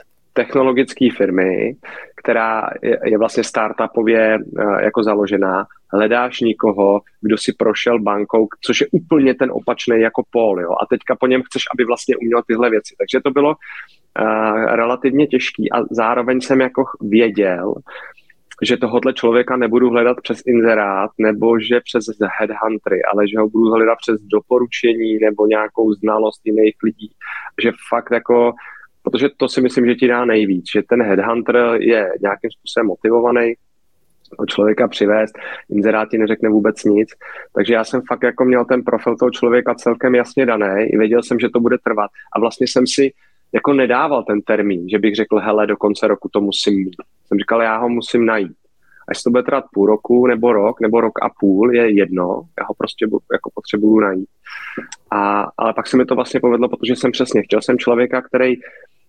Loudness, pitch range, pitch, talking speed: -16 LUFS, 110-125 Hz, 115 Hz, 175 wpm